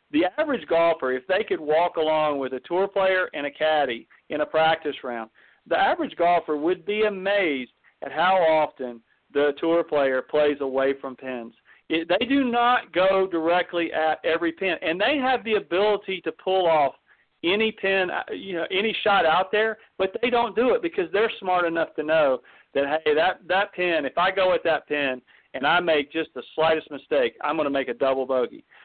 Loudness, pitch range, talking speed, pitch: -23 LUFS, 150-200 Hz, 200 wpm, 170 Hz